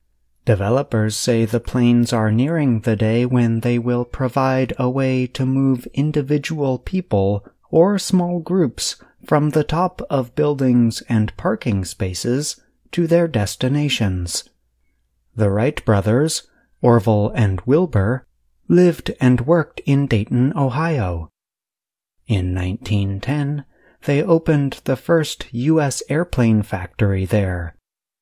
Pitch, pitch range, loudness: 125 Hz, 105-145 Hz, -19 LUFS